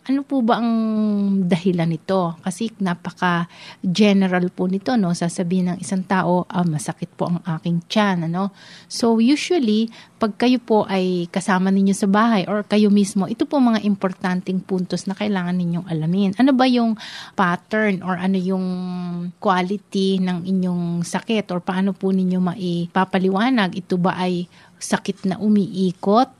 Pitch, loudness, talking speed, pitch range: 190 Hz, -20 LUFS, 155 wpm, 180-210 Hz